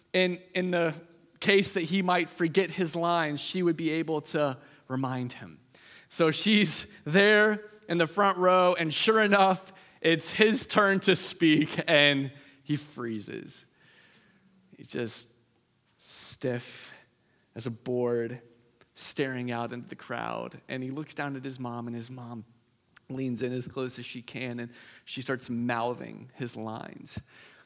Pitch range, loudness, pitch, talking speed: 125-180 Hz, -27 LUFS, 145 Hz, 150 wpm